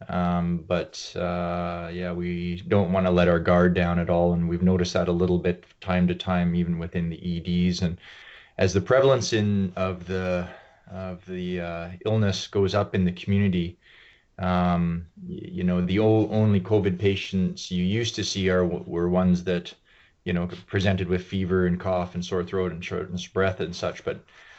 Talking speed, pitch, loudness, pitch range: 190 wpm, 90 Hz, -25 LUFS, 90-95 Hz